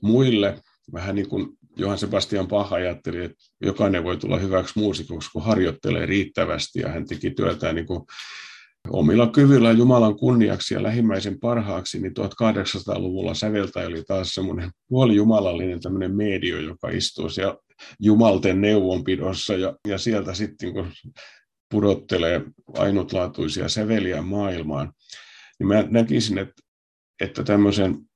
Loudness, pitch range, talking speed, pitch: -22 LUFS, 95-110 Hz, 125 wpm, 100 Hz